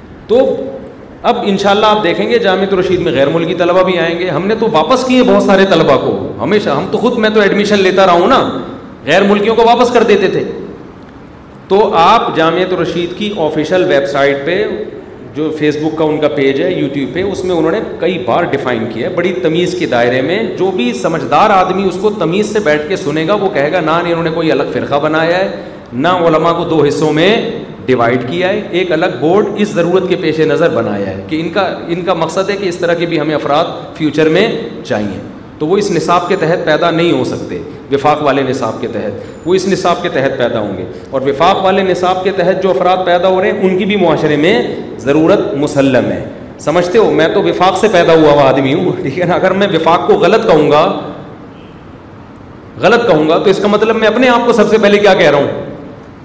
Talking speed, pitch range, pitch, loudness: 230 wpm, 155-195 Hz, 175 Hz, -11 LUFS